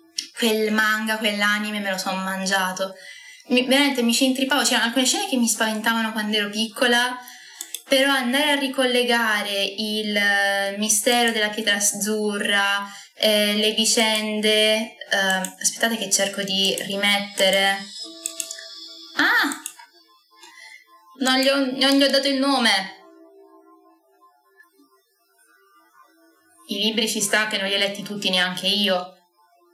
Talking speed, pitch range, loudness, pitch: 120 wpm, 200-270 Hz, -20 LUFS, 215 Hz